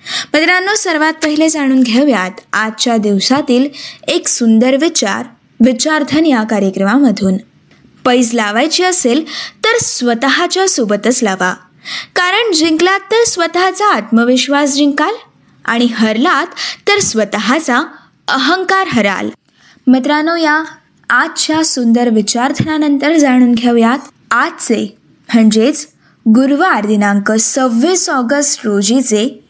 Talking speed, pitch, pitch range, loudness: 95 wpm, 270 Hz, 230-315 Hz, -11 LUFS